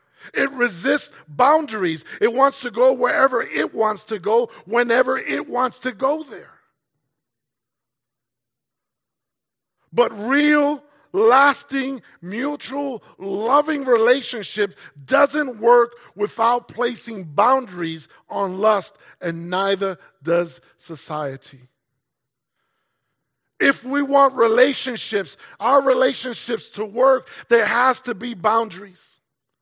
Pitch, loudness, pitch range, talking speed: 240 Hz, -19 LUFS, 195-270 Hz, 95 wpm